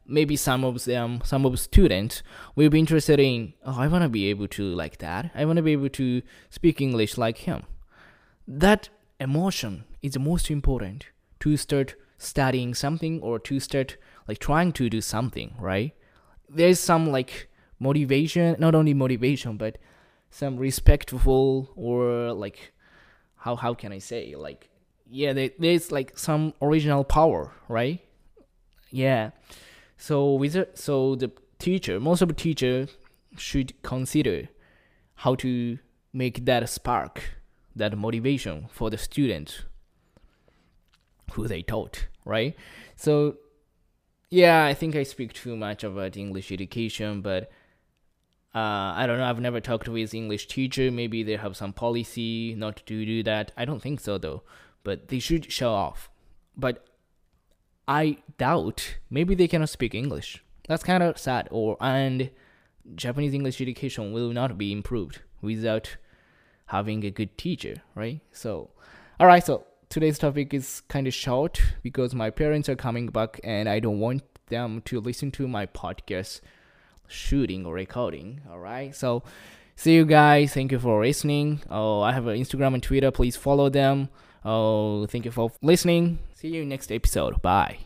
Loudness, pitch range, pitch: -25 LUFS, 110-145 Hz, 130 Hz